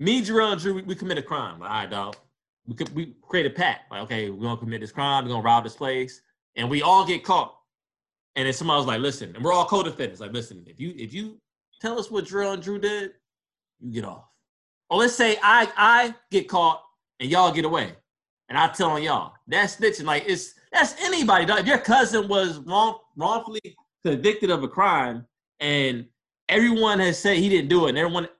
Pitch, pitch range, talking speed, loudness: 180 Hz, 140-210 Hz, 220 wpm, -23 LUFS